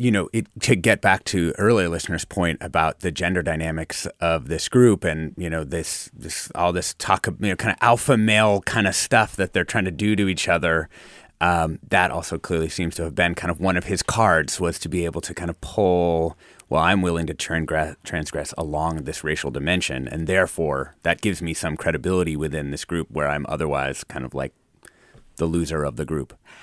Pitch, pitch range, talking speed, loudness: 85 Hz, 80-90 Hz, 215 wpm, -22 LUFS